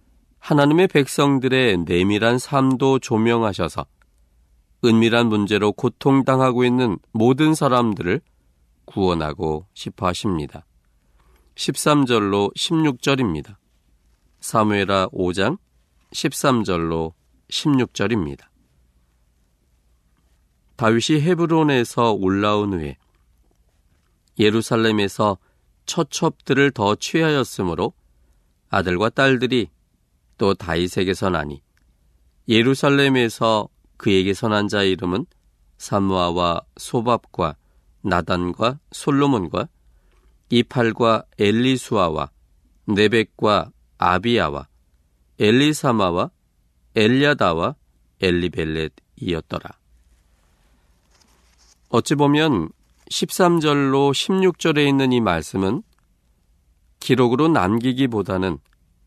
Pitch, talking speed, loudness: 95 Hz, 200 characters per minute, -19 LUFS